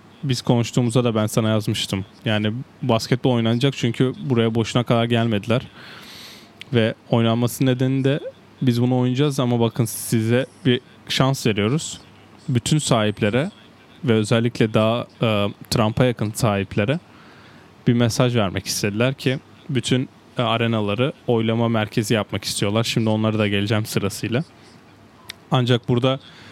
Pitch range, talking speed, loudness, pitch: 110-125 Hz, 120 wpm, -21 LUFS, 115 Hz